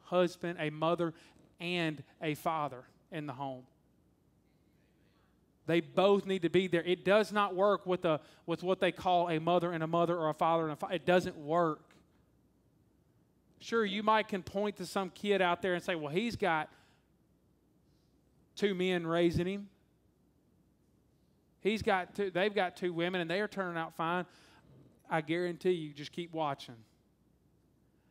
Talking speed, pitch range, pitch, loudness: 165 wpm, 160-190 Hz, 175 Hz, -33 LUFS